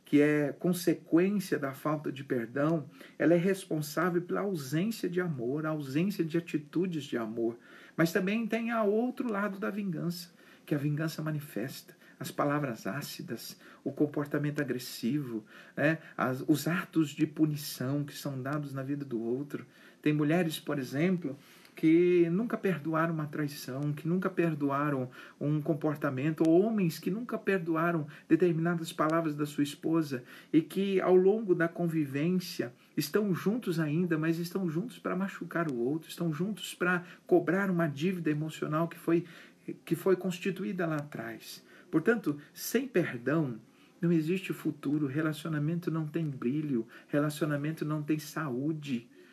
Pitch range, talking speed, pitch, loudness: 150-180 Hz, 145 wpm, 160 Hz, -31 LUFS